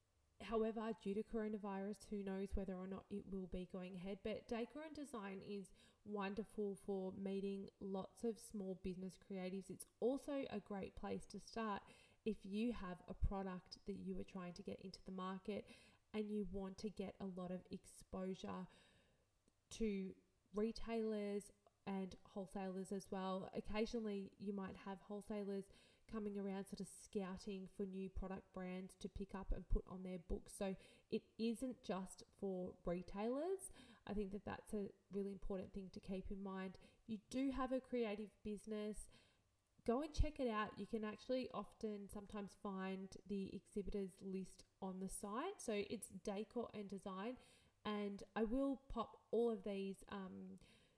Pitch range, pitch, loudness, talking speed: 190-220 Hz, 200 Hz, -48 LUFS, 160 wpm